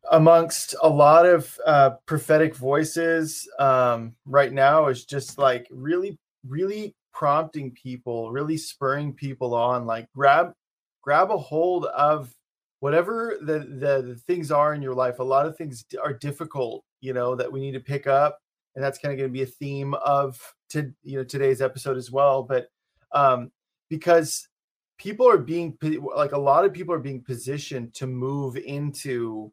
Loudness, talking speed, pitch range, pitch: -23 LUFS, 170 wpm, 130-155 Hz, 140 Hz